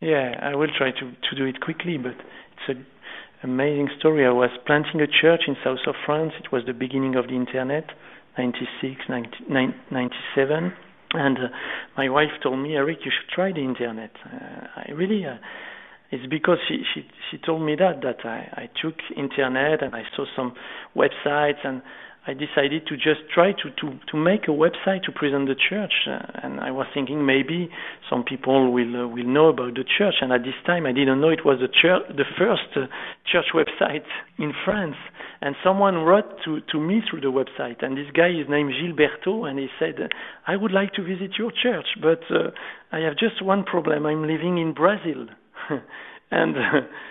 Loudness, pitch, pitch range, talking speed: -23 LUFS, 150 Hz, 130-165 Hz, 195 wpm